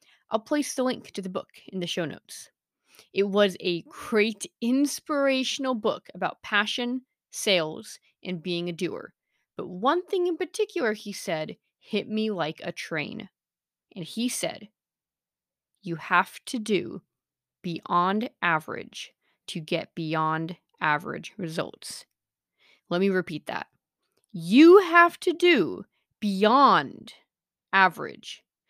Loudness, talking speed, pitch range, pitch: -25 LUFS, 125 wpm, 175-255 Hz, 205 Hz